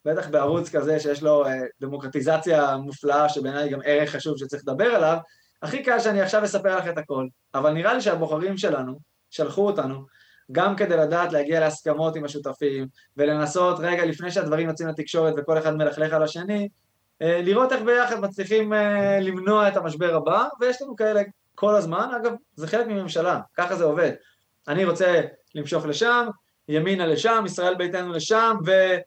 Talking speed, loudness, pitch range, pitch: 160 wpm, -23 LUFS, 150-200 Hz, 165 Hz